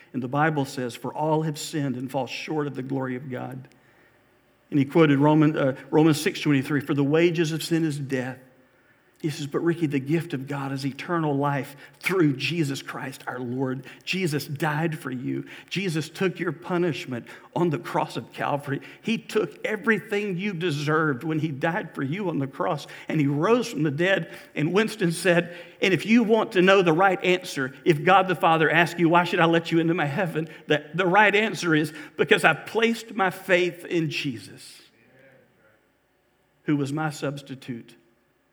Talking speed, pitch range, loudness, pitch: 185 wpm, 140-180 Hz, -24 LUFS, 155 Hz